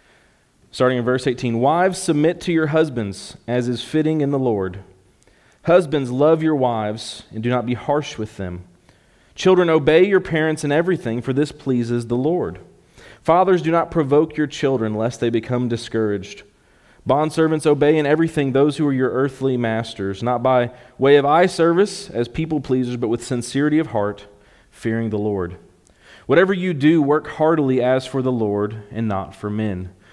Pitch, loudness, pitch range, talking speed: 130 Hz, -19 LUFS, 115-155 Hz, 175 wpm